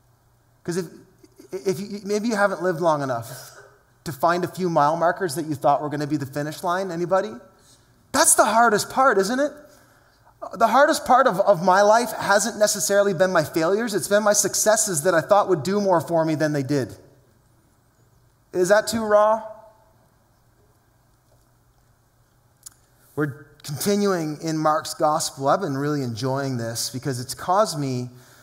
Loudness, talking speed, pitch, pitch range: -21 LUFS, 165 wpm, 160 Hz, 125-200 Hz